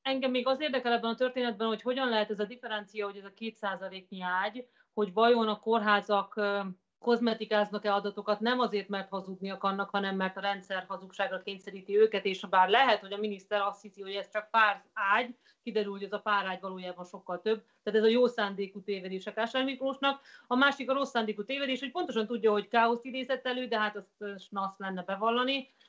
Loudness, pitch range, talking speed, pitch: -31 LUFS, 200-235 Hz, 195 wpm, 210 Hz